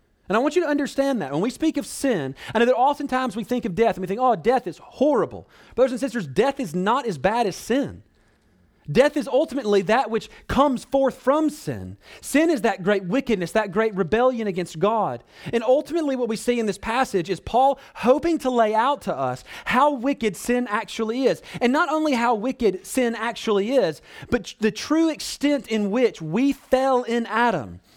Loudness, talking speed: -22 LUFS, 205 wpm